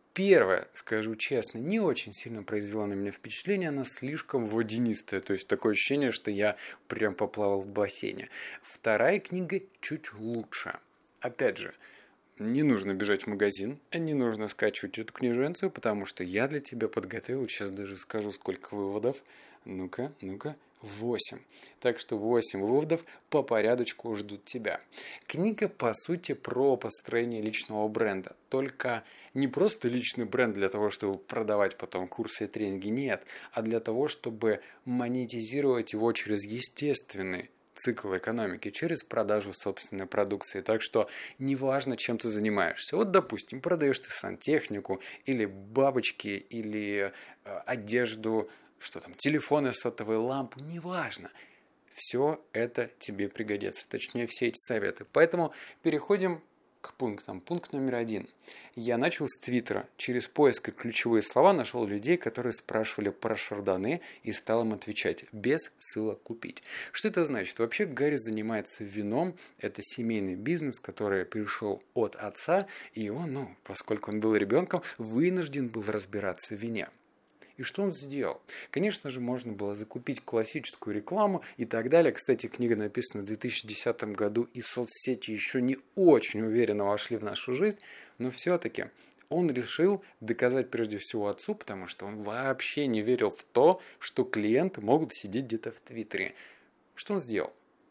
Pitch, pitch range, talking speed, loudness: 115 Hz, 105-135 Hz, 145 wpm, -31 LUFS